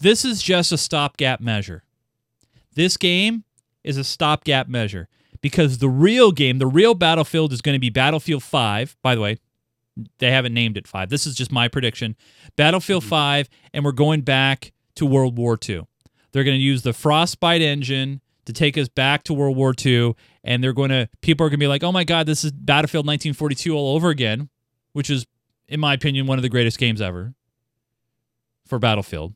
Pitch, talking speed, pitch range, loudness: 135 Hz, 195 wpm, 120-150 Hz, -19 LUFS